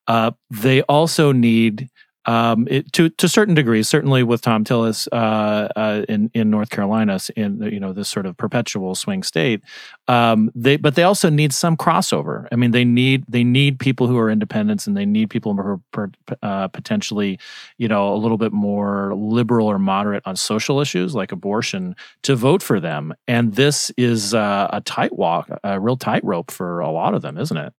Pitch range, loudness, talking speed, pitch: 105-145 Hz, -18 LUFS, 195 wpm, 120 Hz